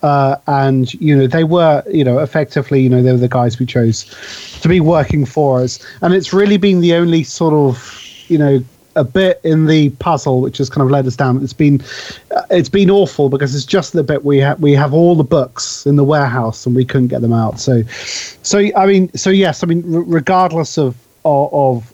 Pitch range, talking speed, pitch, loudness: 130-170 Hz, 230 wpm, 145 Hz, -13 LUFS